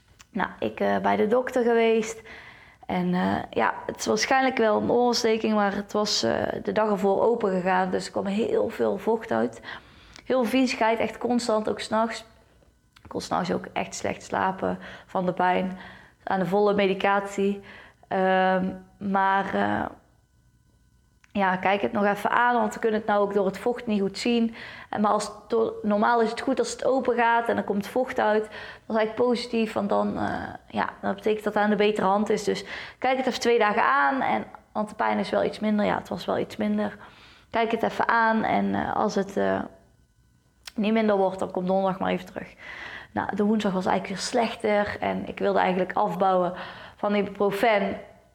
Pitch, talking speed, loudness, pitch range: 210 Hz, 200 wpm, -25 LUFS, 195-230 Hz